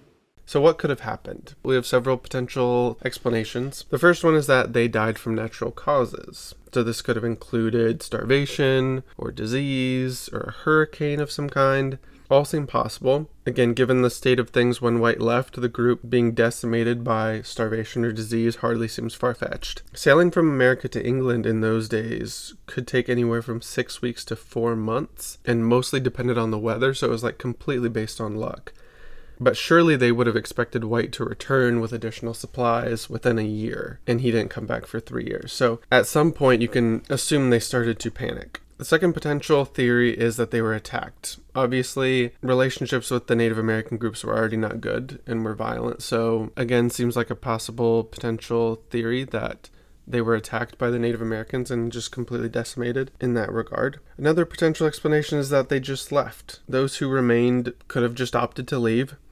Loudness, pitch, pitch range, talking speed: -23 LUFS, 120 Hz, 115-130 Hz, 190 wpm